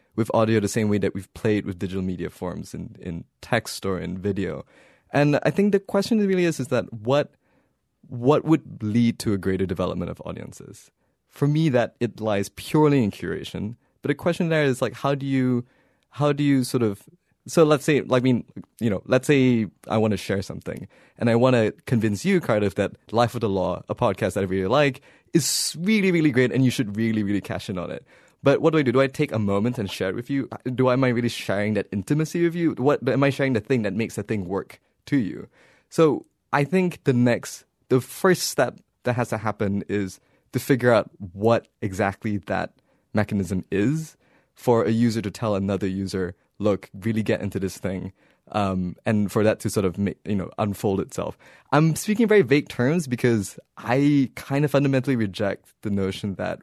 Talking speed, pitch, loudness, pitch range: 215 wpm, 115 Hz, -23 LUFS, 100-140 Hz